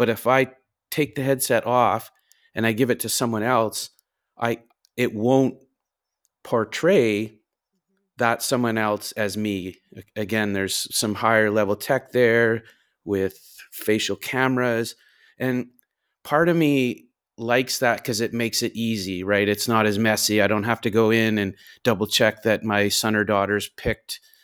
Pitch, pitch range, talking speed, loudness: 115 Hz, 105-125 Hz, 155 wpm, -22 LUFS